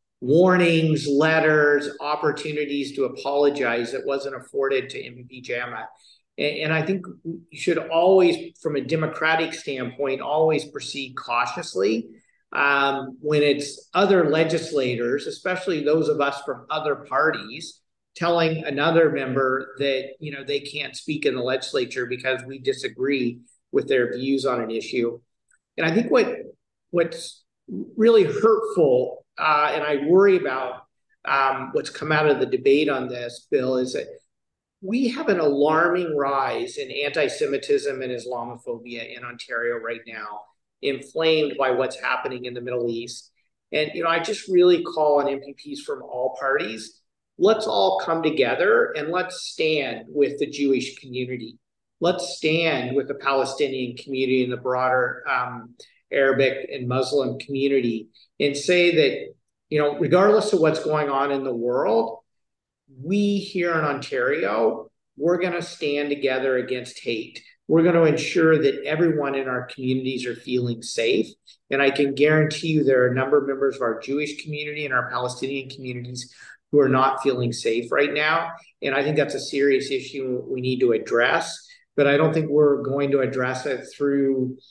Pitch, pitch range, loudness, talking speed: 140 Hz, 130-160 Hz, -22 LUFS, 155 wpm